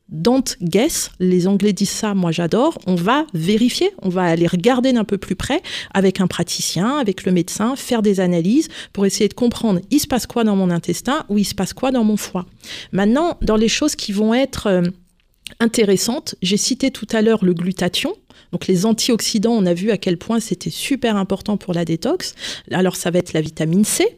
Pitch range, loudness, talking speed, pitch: 180-235 Hz, -18 LUFS, 210 wpm, 205 Hz